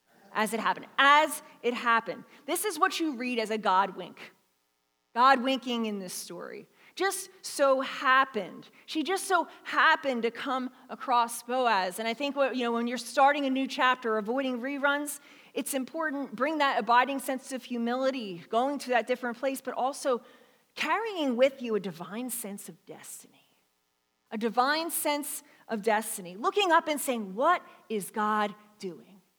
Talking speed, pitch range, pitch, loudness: 165 wpm, 220-285 Hz, 255 Hz, -28 LUFS